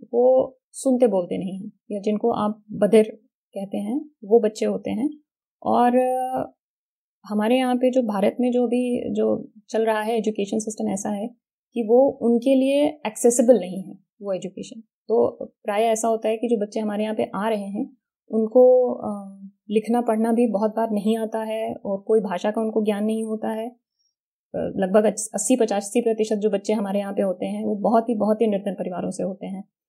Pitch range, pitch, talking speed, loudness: 210-245 Hz, 220 Hz, 185 wpm, -22 LUFS